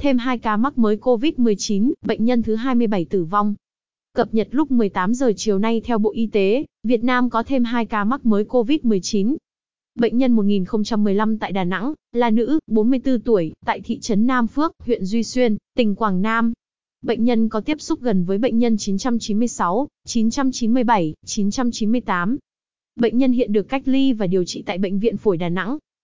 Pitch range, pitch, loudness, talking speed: 210-250 Hz, 230 Hz, -20 LUFS, 185 wpm